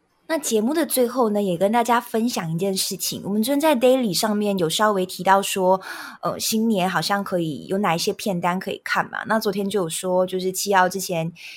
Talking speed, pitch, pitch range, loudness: 330 characters per minute, 200 Hz, 185-225 Hz, -21 LUFS